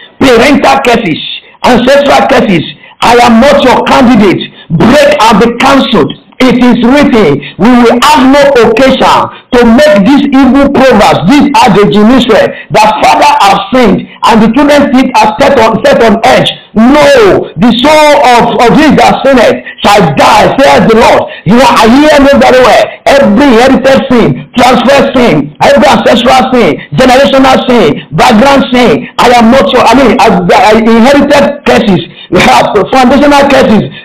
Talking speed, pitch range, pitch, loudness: 150 wpm, 225-275 Hz, 250 Hz, -3 LUFS